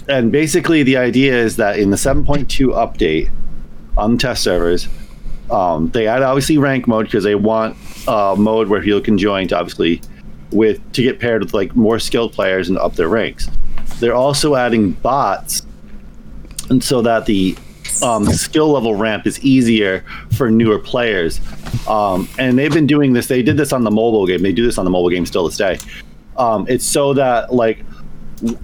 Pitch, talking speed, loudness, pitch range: 115 Hz, 185 wpm, -15 LUFS, 100-130 Hz